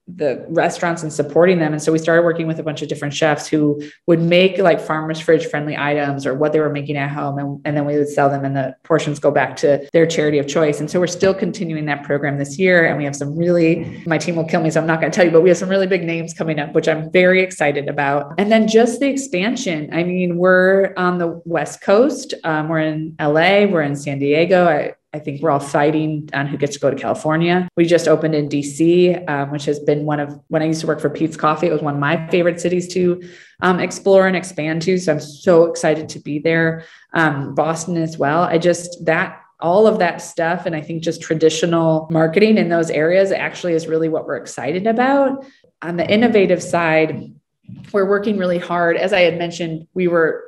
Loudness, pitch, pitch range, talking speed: -17 LUFS, 165 Hz, 150-175 Hz, 240 wpm